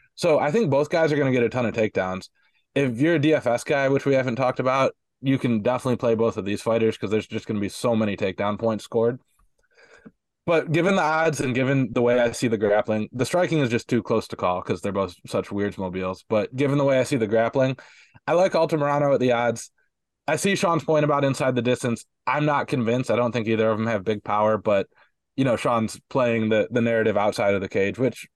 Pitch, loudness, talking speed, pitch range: 120 Hz, -23 LUFS, 245 wpm, 110-140 Hz